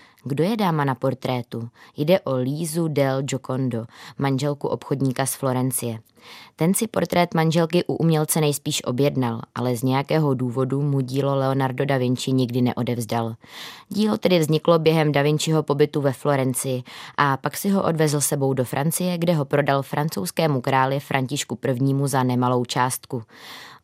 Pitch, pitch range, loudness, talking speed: 140 Hz, 130-155 Hz, -22 LUFS, 150 wpm